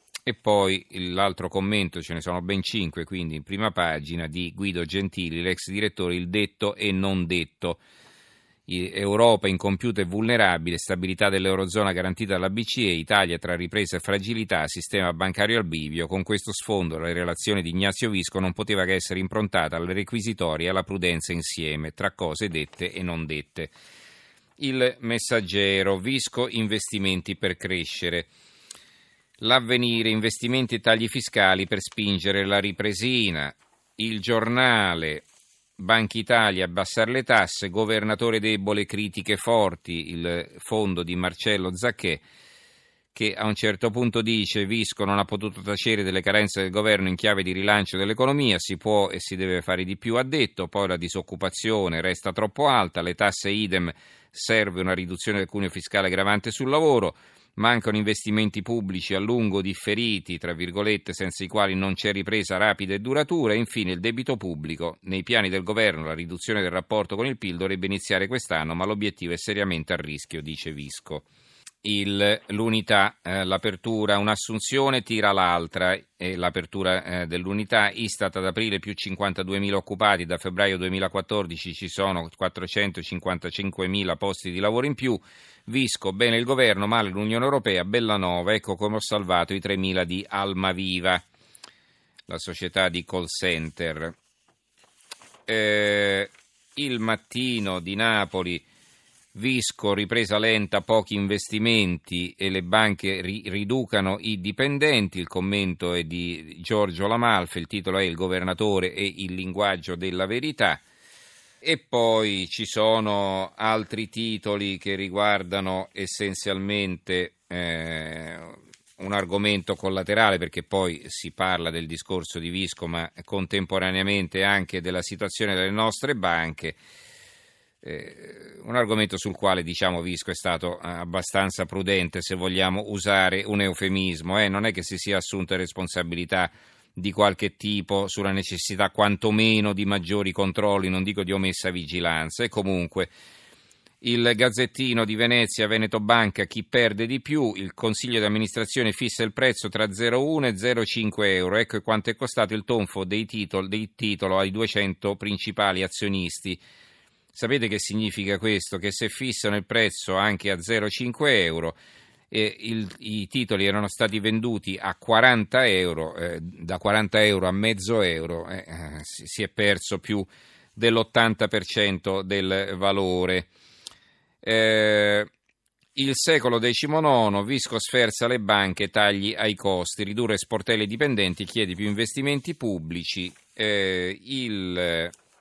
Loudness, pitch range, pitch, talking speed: -24 LUFS, 90-110 Hz, 100 Hz, 140 wpm